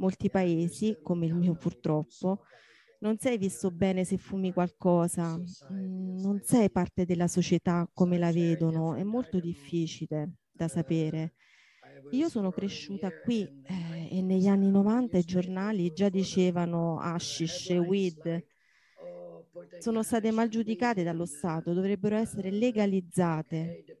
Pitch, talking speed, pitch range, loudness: 180 Hz, 125 wpm, 170-200 Hz, -30 LUFS